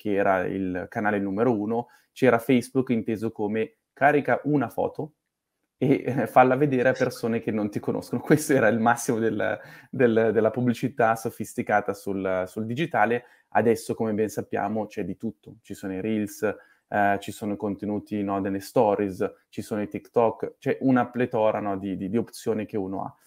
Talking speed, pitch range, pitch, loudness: 180 wpm, 100-120 Hz, 110 Hz, -25 LUFS